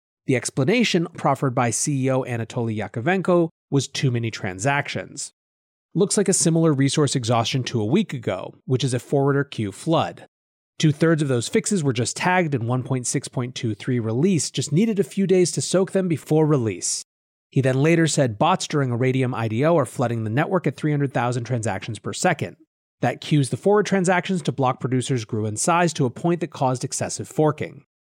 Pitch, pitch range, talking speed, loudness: 140 Hz, 125-165 Hz, 180 wpm, -22 LUFS